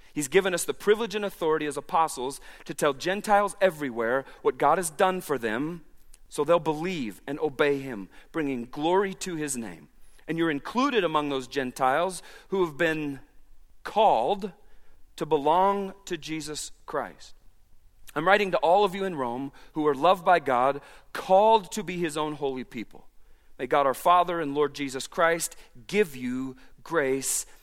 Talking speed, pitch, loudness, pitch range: 165 wpm, 155 Hz, -26 LUFS, 140-185 Hz